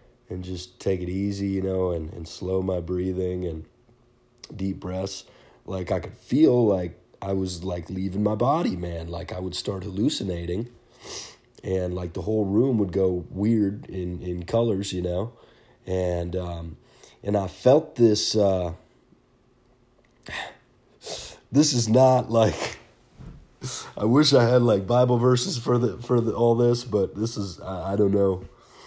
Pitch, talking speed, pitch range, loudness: 95 Hz, 160 wpm, 90-115 Hz, -24 LUFS